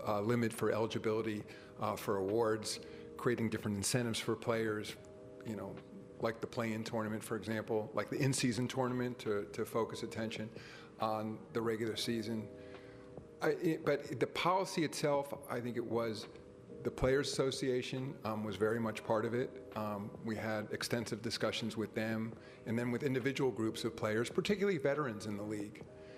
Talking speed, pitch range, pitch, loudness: 165 wpm, 110-125 Hz, 115 Hz, -37 LUFS